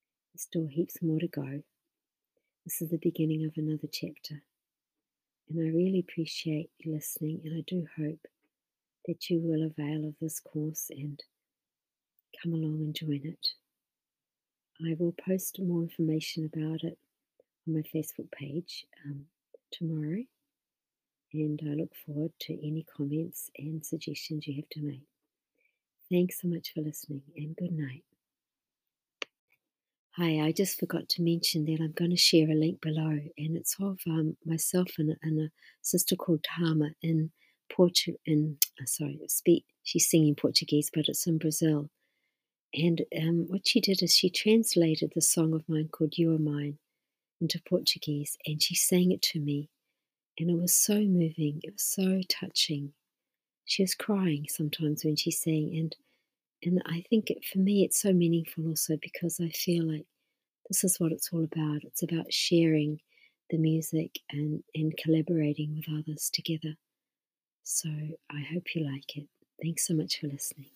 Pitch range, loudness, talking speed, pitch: 155-170 Hz, -30 LUFS, 160 wpm, 160 Hz